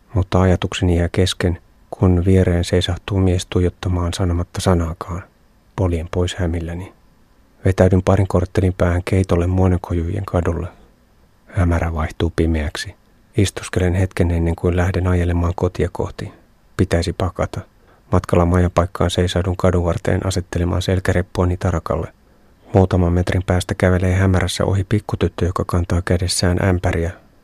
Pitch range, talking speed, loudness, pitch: 85-95 Hz, 115 wpm, -19 LUFS, 90 Hz